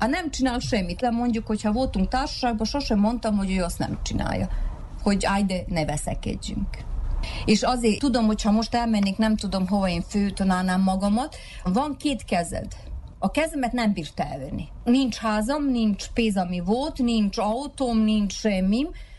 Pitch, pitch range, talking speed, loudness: 220 Hz, 195-245 Hz, 160 wpm, -25 LUFS